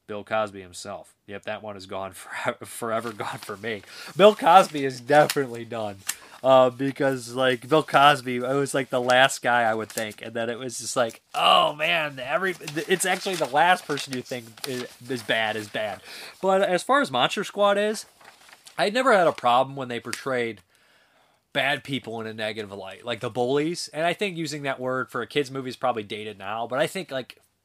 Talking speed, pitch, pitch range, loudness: 205 wpm, 130 Hz, 115-150 Hz, -24 LUFS